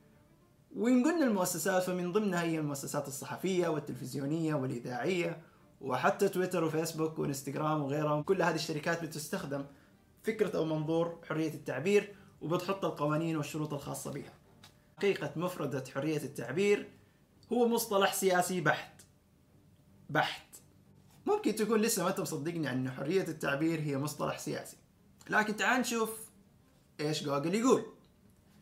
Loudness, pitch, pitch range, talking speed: -33 LUFS, 165 Hz, 150-190 Hz, 115 wpm